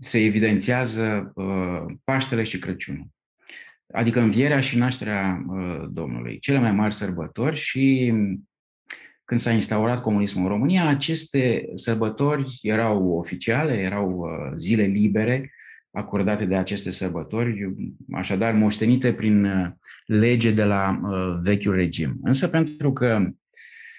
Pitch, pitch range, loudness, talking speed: 105 Hz, 95-125 Hz, -23 LUFS, 110 wpm